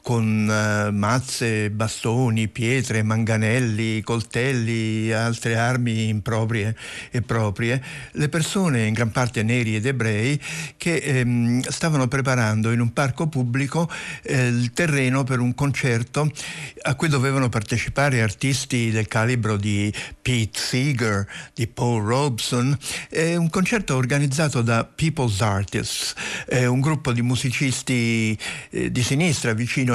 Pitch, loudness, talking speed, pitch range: 125 Hz, -22 LUFS, 125 wpm, 115-135 Hz